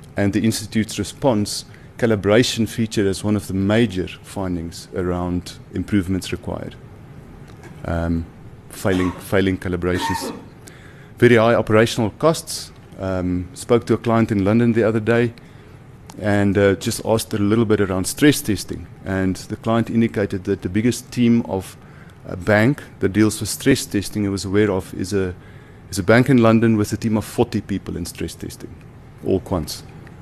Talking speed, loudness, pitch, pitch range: 160 wpm, -20 LUFS, 105 Hz, 95-120 Hz